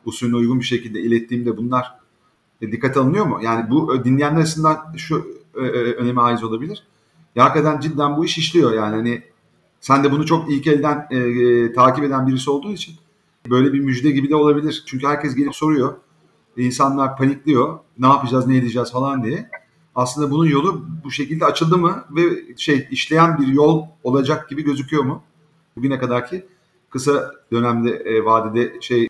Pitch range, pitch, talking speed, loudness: 125-155 Hz, 140 Hz, 170 wpm, -18 LUFS